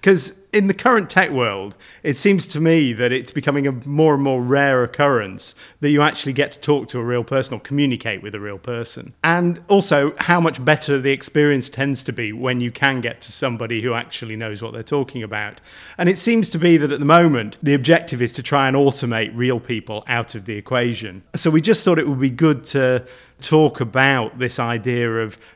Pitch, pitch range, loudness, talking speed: 135 Hz, 120-155 Hz, -18 LUFS, 220 wpm